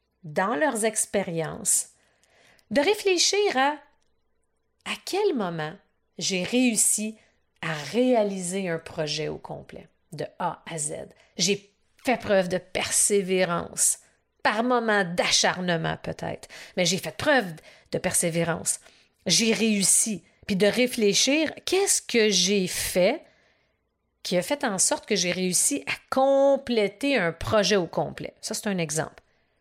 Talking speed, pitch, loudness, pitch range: 130 wpm, 205 Hz, -24 LUFS, 180-250 Hz